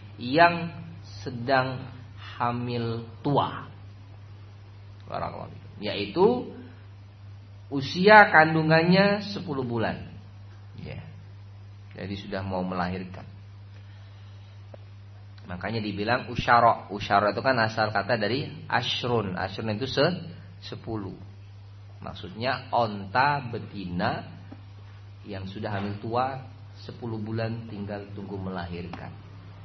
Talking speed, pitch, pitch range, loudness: 85 wpm, 100 Hz, 100-120 Hz, -25 LUFS